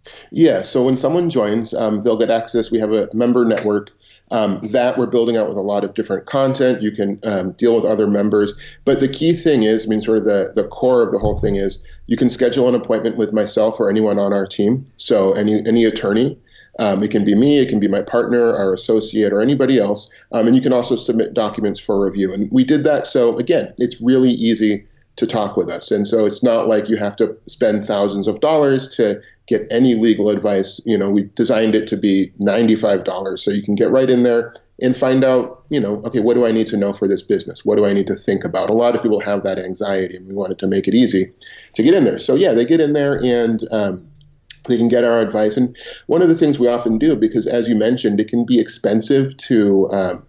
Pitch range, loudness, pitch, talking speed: 105-125 Hz, -16 LUFS, 110 Hz, 245 wpm